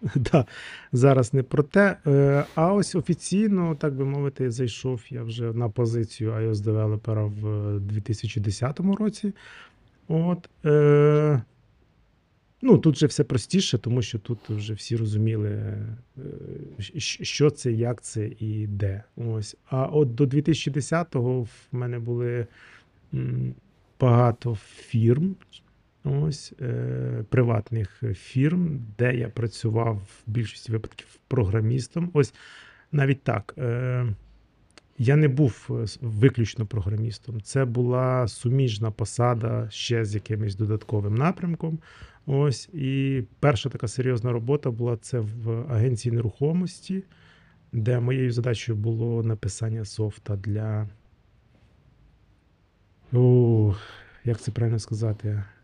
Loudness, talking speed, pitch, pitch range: -25 LUFS, 110 wpm, 120 Hz, 110-135 Hz